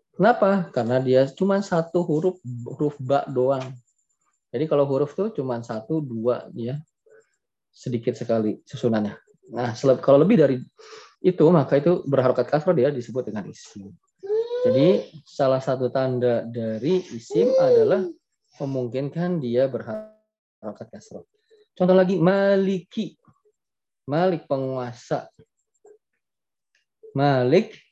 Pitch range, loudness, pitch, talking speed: 125-195 Hz, -22 LUFS, 145 Hz, 105 wpm